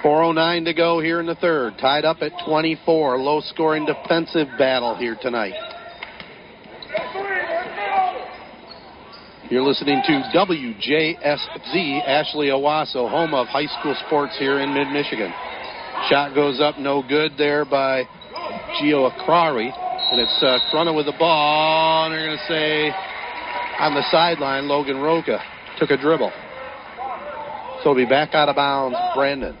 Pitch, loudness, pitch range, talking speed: 155 Hz, -20 LUFS, 145-170 Hz, 140 wpm